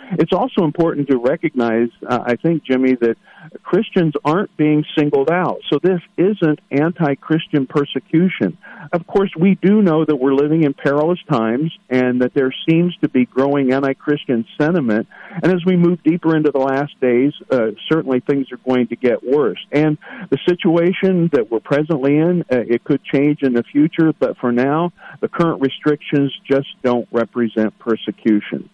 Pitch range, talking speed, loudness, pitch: 130-170 Hz, 175 wpm, -17 LUFS, 150 Hz